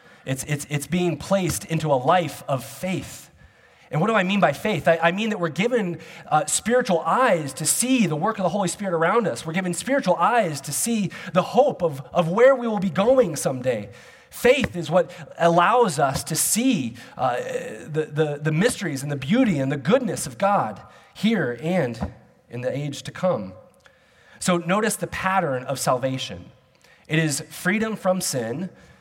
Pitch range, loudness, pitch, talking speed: 155-205 Hz, -22 LUFS, 175 Hz, 185 wpm